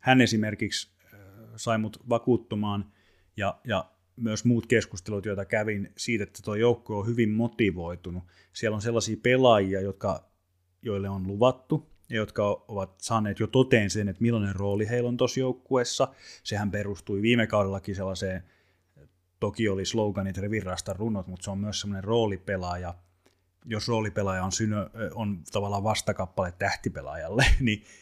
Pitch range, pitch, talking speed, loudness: 95-115 Hz, 105 Hz, 140 wpm, -28 LUFS